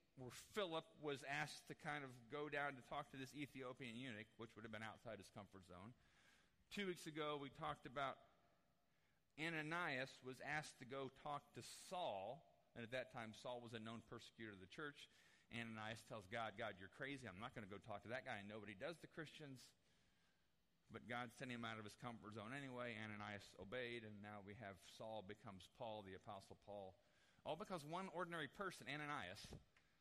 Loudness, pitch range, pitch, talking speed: -53 LUFS, 110-145 Hz, 120 Hz, 195 wpm